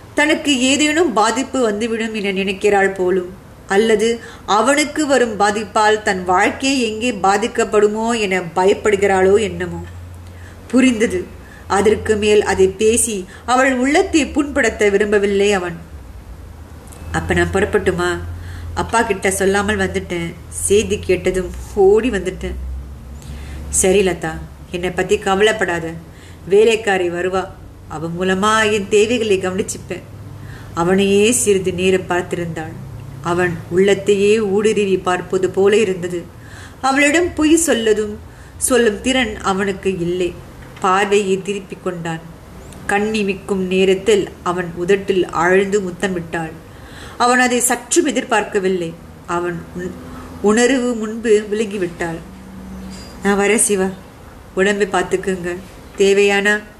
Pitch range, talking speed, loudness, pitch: 180-215 Hz, 100 wpm, -16 LUFS, 195 Hz